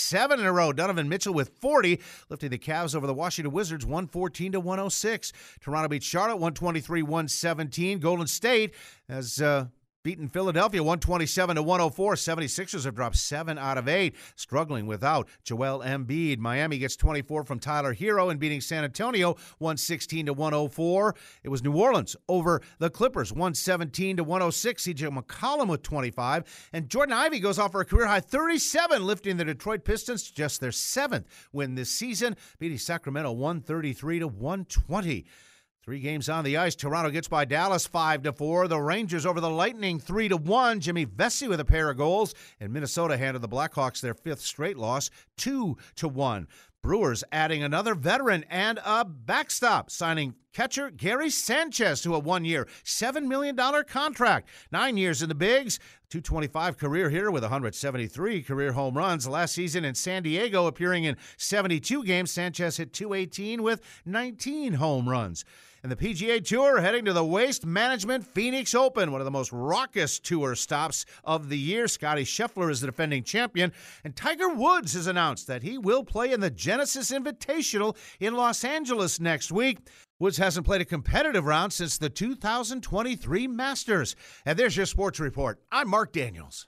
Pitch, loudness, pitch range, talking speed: 170 Hz, -27 LUFS, 150-210 Hz, 175 wpm